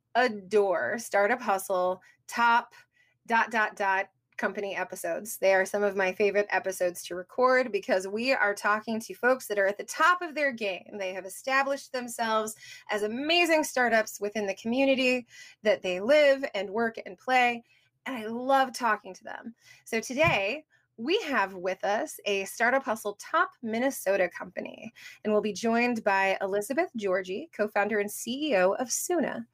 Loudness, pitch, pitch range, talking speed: -27 LUFS, 215 Hz, 195-255 Hz, 165 wpm